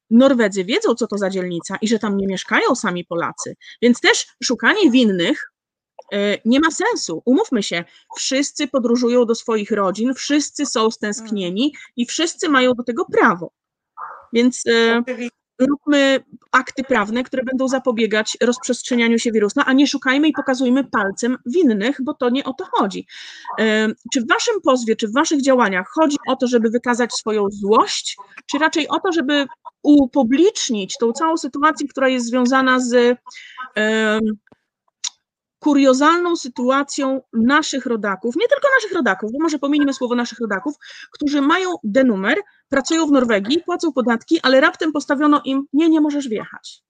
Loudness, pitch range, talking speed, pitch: -18 LUFS, 230-295 Hz, 150 wpm, 260 Hz